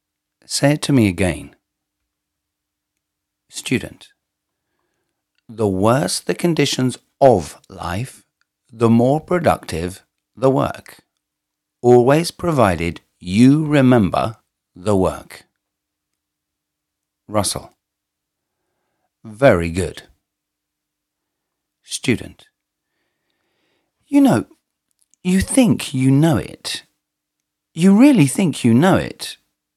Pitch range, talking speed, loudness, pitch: 85-145 Hz, 80 wpm, -17 LUFS, 115 Hz